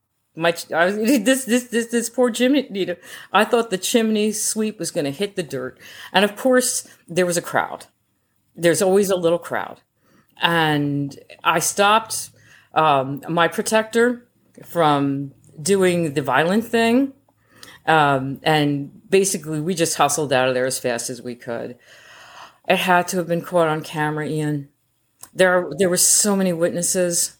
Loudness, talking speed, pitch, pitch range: -19 LUFS, 160 wpm, 170 Hz, 145-205 Hz